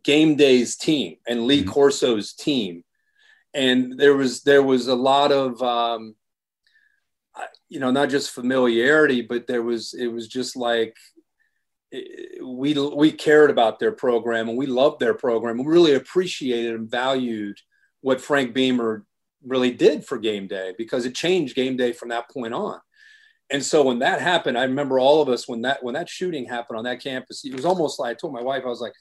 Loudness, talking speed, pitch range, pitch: -21 LUFS, 190 wpm, 120-150 Hz, 130 Hz